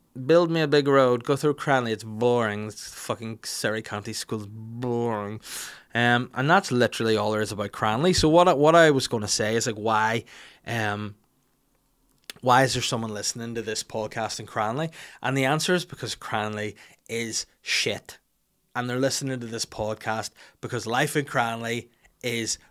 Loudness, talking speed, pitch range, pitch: -25 LUFS, 175 wpm, 110-135 Hz, 115 Hz